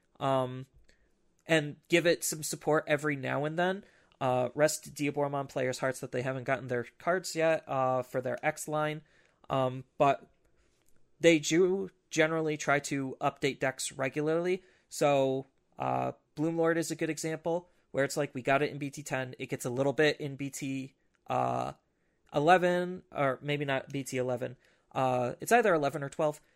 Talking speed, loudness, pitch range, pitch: 165 wpm, -31 LUFS, 130-160 Hz, 145 Hz